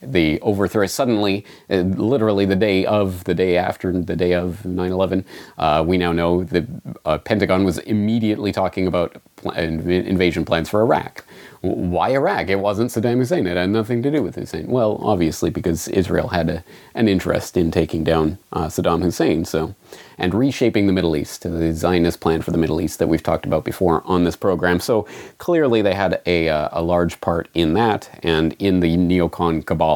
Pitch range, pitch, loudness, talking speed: 85-100 Hz, 90 Hz, -19 LUFS, 190 wpm